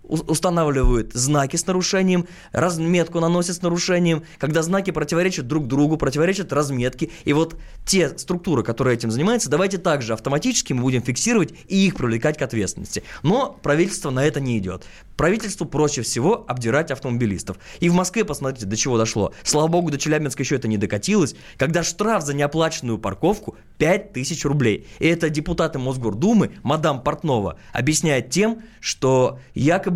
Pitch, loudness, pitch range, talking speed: 150 Hz, -21 LUFS, 130-175 Hz, 150 wpm